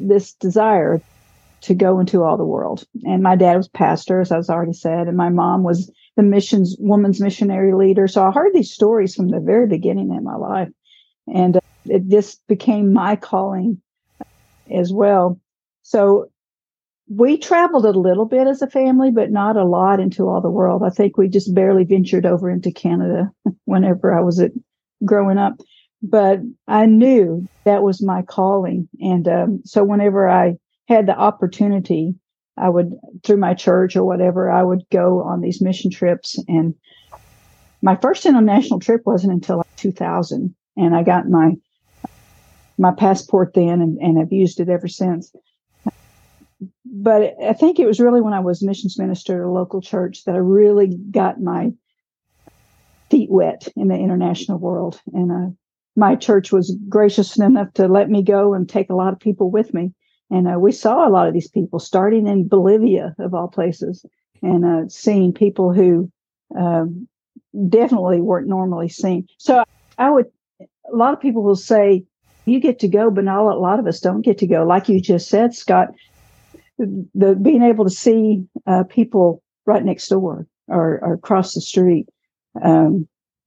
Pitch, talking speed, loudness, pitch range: 195 Hz, 175 wpm, -16 LUFS, 180-210 Hz